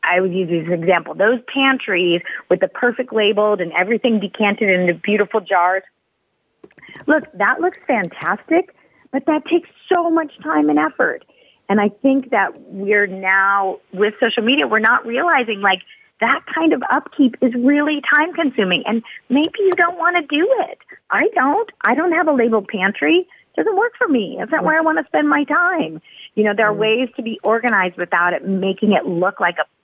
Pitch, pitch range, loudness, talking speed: 220 Hz, 190-300 Hz, -17 LUFS, 190 wpm